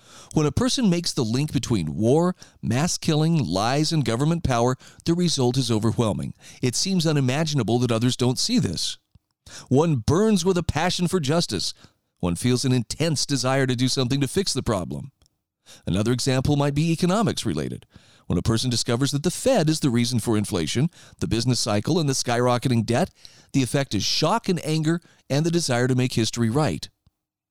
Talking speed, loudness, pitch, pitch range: 180 wpm, -23 LUFS, 130 Hz, 120-160 Hz